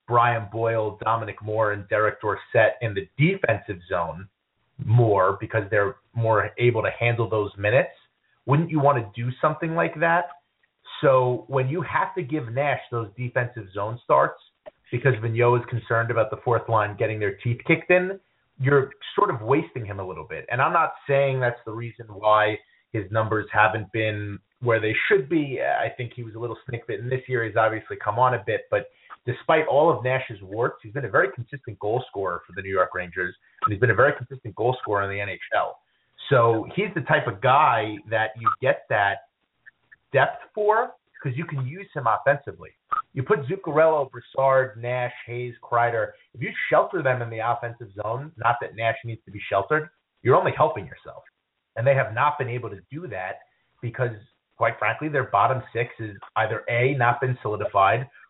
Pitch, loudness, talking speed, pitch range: 120 Hz, -24 LUFS, 190 wpm, 110-140 Hz